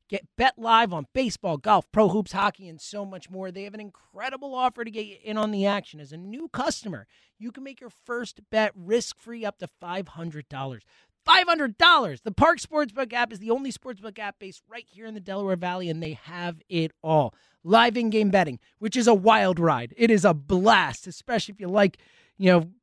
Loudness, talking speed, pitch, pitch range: -23 LUFS, 215 wpm, 210 Hz, 180-235 Hz